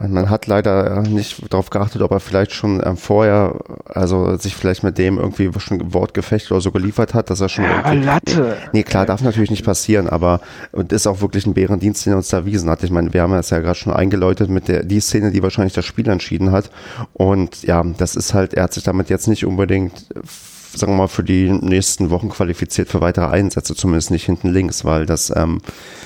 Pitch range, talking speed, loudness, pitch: 90-105 Hz, 220 wpm, -17 LUFS, 95 Hz